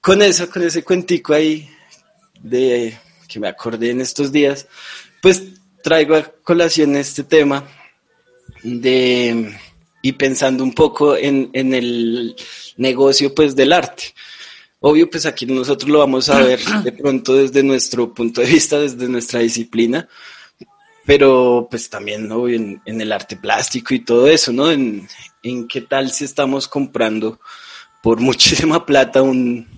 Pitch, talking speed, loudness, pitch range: 135 Hz, 145 wpm, -15 LUFS, 120-155 Hz